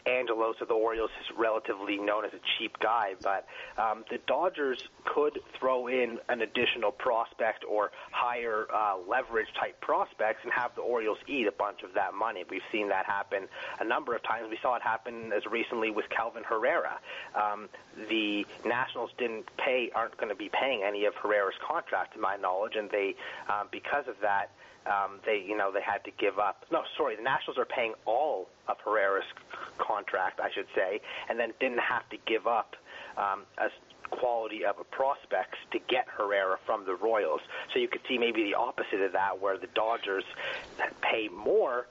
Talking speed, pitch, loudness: 190 wpm, 380 Hz, -31 LUFS